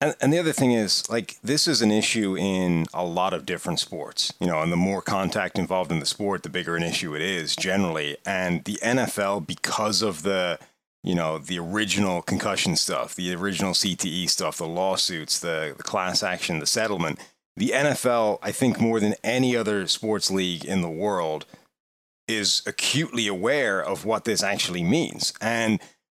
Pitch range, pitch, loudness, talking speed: 85-110 Hz, 95 Hz, -24 LUFS, 185 wpm